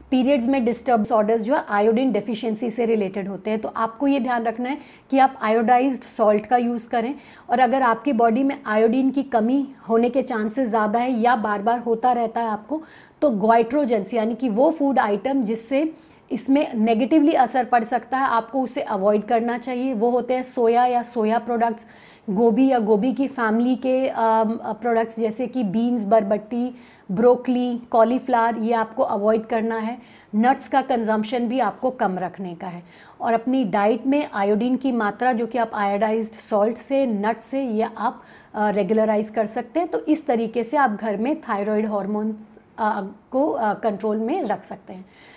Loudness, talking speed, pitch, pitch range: -21 LUFS, 180 wpm, 235 Hz, 220-255 Hz